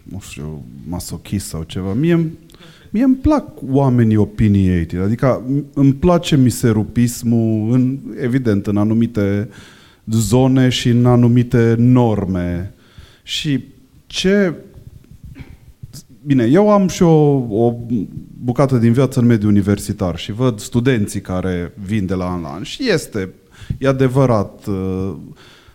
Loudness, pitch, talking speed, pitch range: -16 LUFS, 120 Hz, 120 wpm, 100-135 Hz